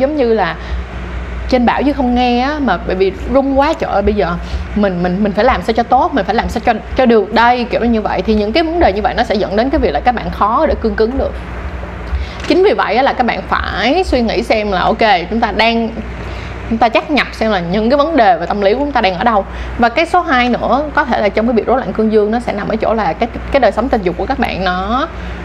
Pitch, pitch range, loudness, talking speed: 230 Hz, 200-260 Hz, -13 LUFS, 290 wpm